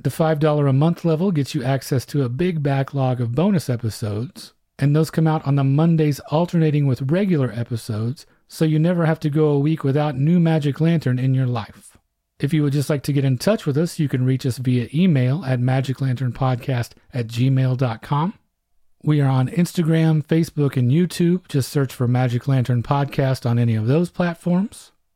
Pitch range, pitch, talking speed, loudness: 130-160 Hz, 140 Hz, 190 wpm, -20 LUFS